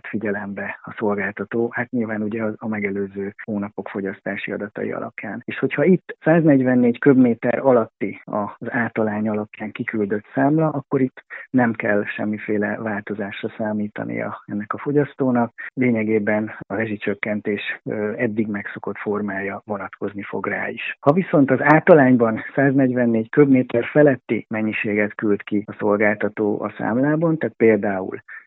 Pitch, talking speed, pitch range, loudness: 110 Hz, 125 wpm, 105-125 Hz, -21 LUFS